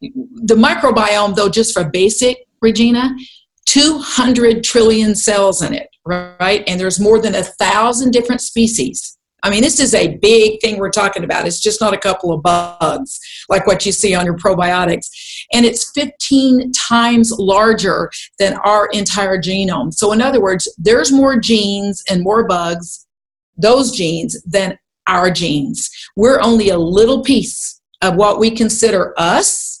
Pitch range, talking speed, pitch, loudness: 190-235 Hz, 160 wpm, 215 Hz, -13 LUFS